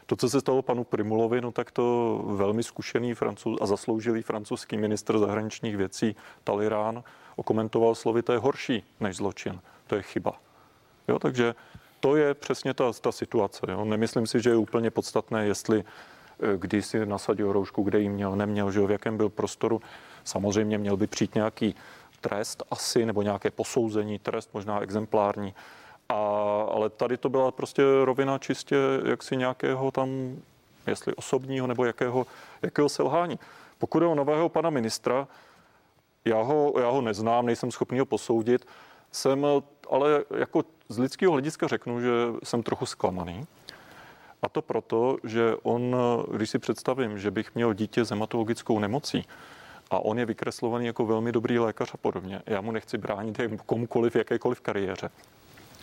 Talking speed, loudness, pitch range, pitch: 160 wpm, -28 LUFS, 105-125 Hz, 115 Hz